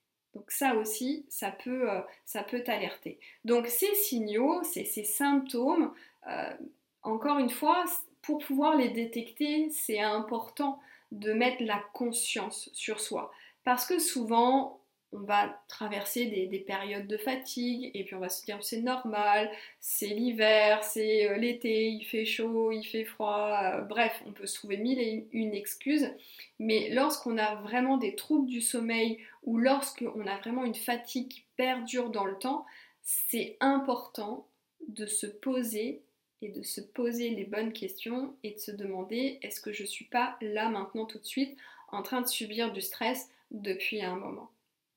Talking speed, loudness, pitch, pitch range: 165 wpm, -31 LUFS, 230 Hz, 210-255 Hz